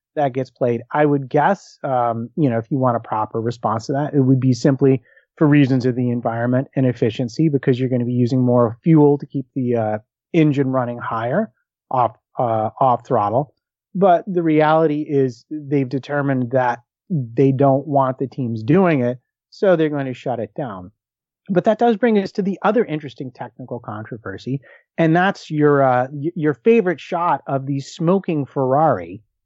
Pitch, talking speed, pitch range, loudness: 135 Hz, 185 wpm, 125-155 Hz, -19 LUFS